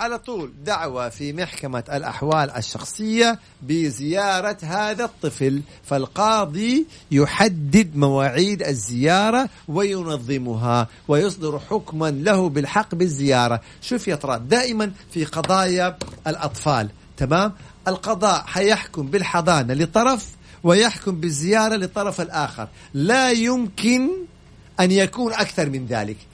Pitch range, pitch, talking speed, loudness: 140-210 Hz, 170 Hz, 95 wpm, -21 LUFS